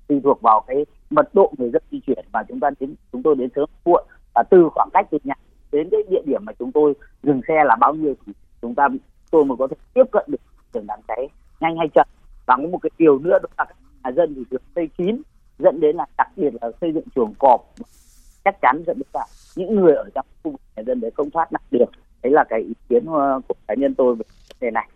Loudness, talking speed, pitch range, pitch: -20 LUFS, 255 wpm, 130-200 Hz, 155 Hz